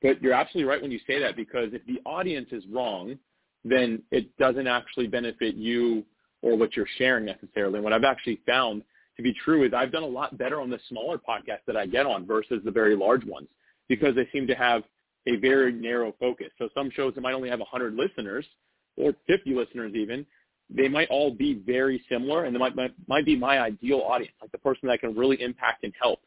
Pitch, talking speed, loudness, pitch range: 125 Hz, 225 wpm, -26 LUFS, 115-135 Hz